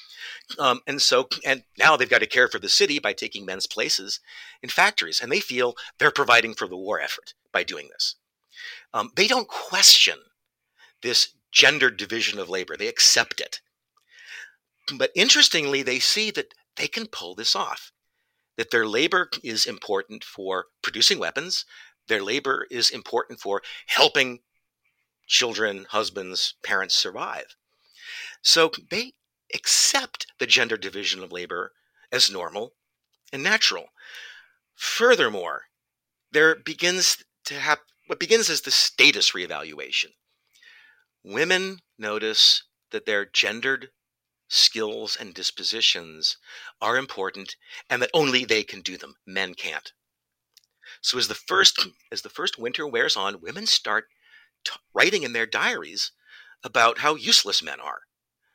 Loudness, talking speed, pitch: -21 LUFS, 135 wpm, 255 Hz